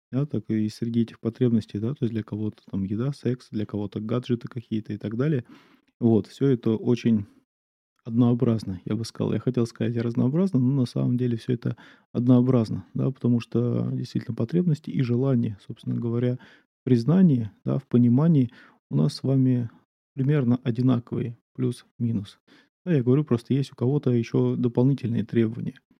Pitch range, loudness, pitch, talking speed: 110-130 Hz, -25 LUFS, 120 Hz, 165 wpm